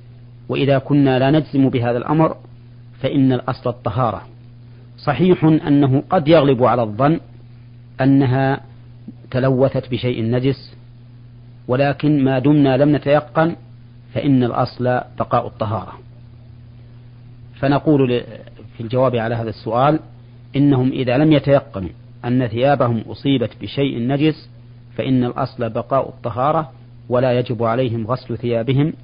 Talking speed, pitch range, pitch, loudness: 105 wpm, 120-135 Hz, 125 Hz, -18 LUFS